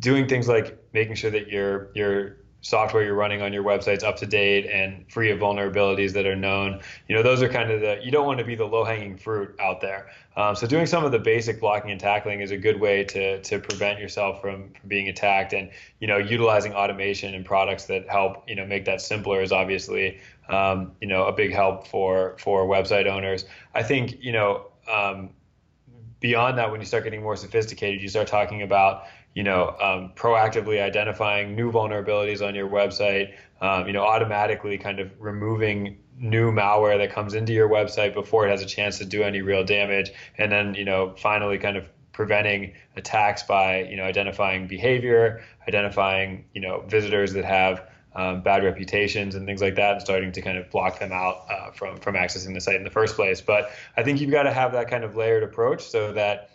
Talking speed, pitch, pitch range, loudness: 210 wpm, 100 Hz, 95-110 Hz, -23 LUFS